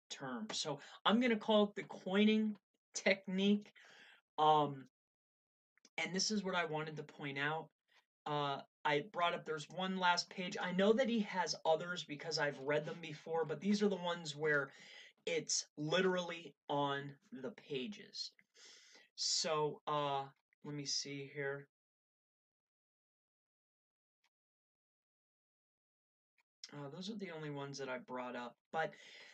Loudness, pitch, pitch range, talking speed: -38 LUFS, 160 Hz, 145-200 Hz, 135 wpm